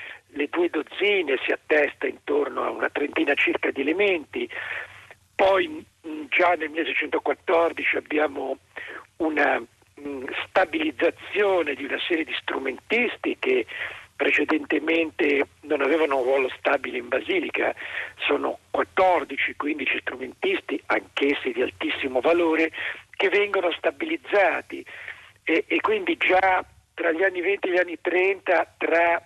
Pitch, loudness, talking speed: 195 Hz, -24 LUFS, 120 wpm